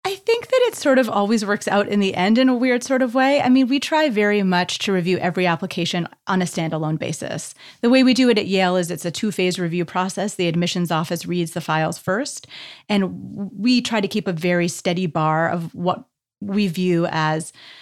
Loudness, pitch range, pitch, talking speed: -20 LUFS, 175-235 Hz, 190 Hz, 225 wpm